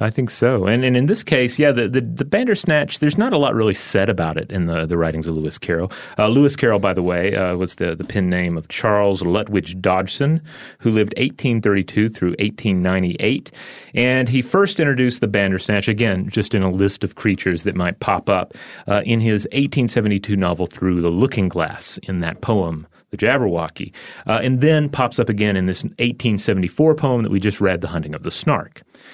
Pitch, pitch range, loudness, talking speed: 105 Hz, 95-125 Hz, -19 LUFS, 205 wpm